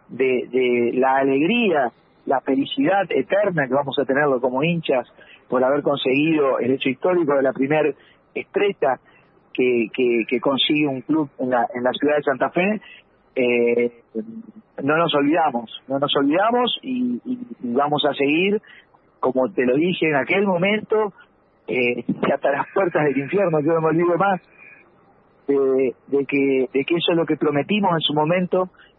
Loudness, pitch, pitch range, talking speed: -20 LUFS, 145 Hz, 130-185 Hz, 165 wpm